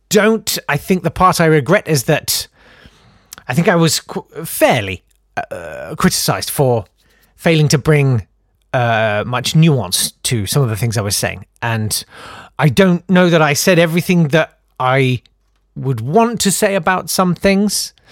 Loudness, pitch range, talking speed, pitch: -15 LUFS, 115-180 Hz, 160 wpm, 150 Hz